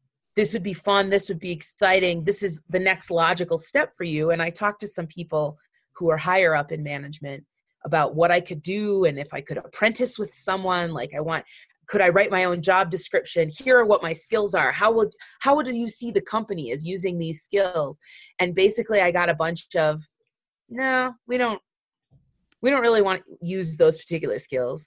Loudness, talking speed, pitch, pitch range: -23 LUFS, 205 wpm, 185 Hz, 165-205 Hz